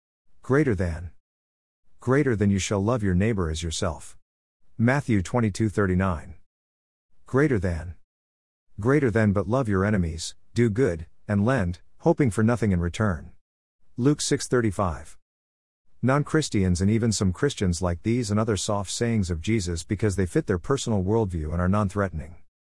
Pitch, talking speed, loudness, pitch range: 100 Hz, 145 wpm, -25 LUFS, 85-115 Hz